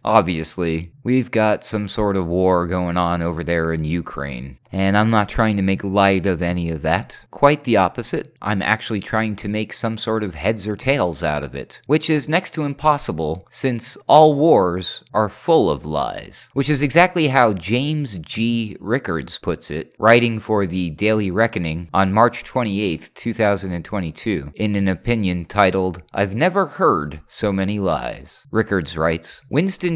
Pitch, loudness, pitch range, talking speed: 105 Hz, -19 LUFS, 90-120 Hz, 170 wpm